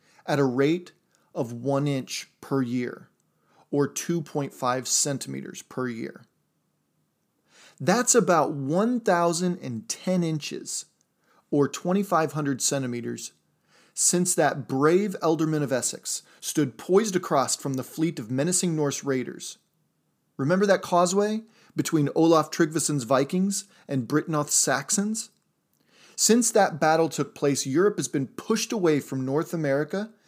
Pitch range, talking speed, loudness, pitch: 140-180 Hz, 115 wpm, -25 LUFS, 155 Hz